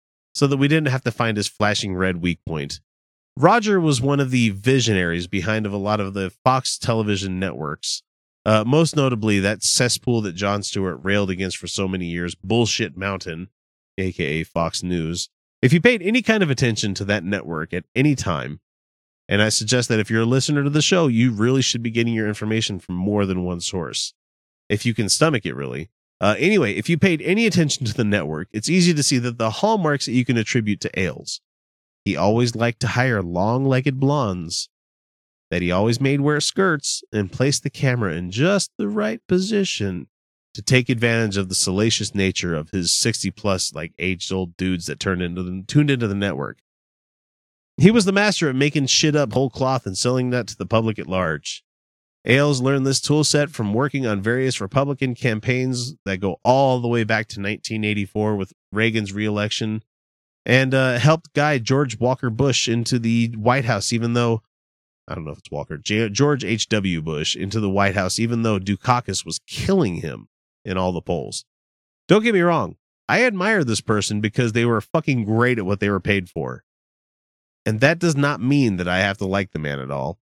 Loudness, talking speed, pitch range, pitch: -20 LUFS, 200 wpm, 95-130 Hz, 110 Hz